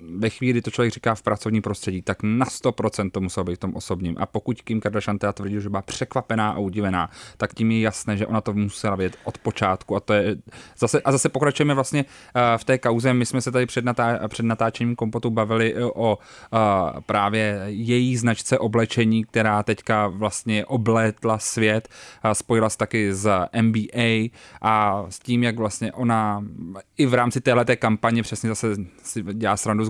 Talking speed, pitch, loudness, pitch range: 180 wpm, 110 Hz, -23 LUFS, 105-120 Hz